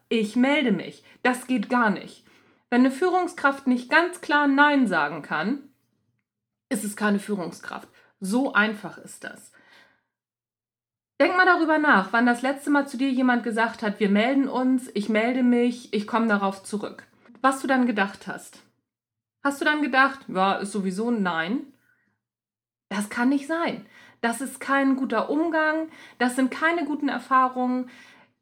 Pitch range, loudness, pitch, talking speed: 205-275 Hz, -23 LUFS, 245 Hz, 160 wpm